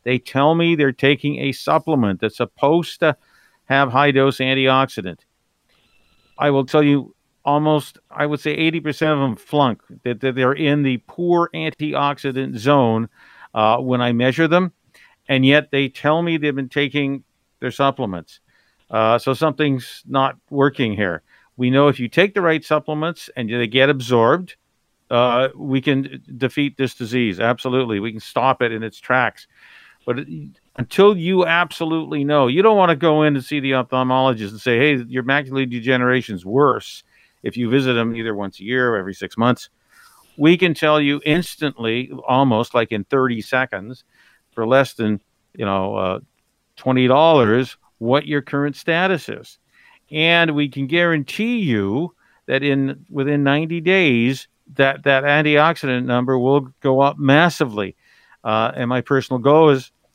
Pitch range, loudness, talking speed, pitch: 125-150 Hz, -18 LUFS, 160 wpm, 135 Hz